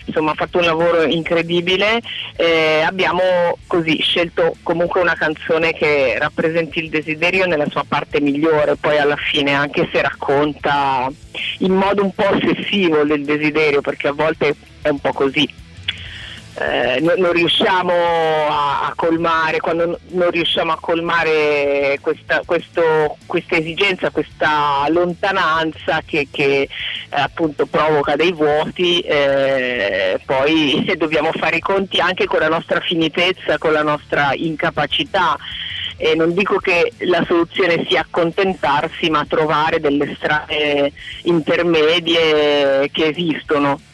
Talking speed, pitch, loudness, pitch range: 130 wpm, 160 Hz, -16 LUFS, 145-175 Hz